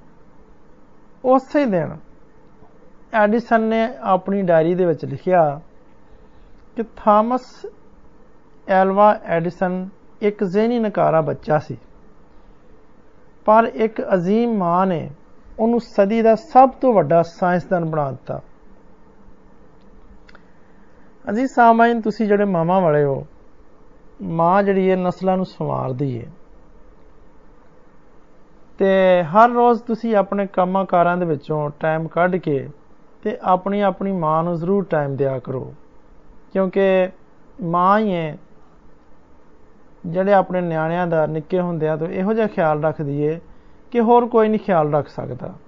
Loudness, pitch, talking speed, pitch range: -18 LUFS, 185 Hz, 115 wpm, 160-215 Hz